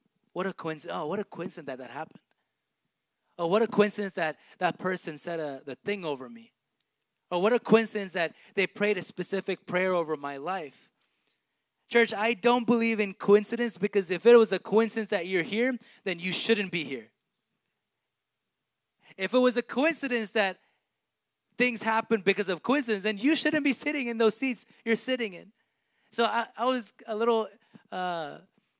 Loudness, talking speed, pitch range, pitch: -28 LUFS, 175 wpm, 180-230 Hz, 210 Hz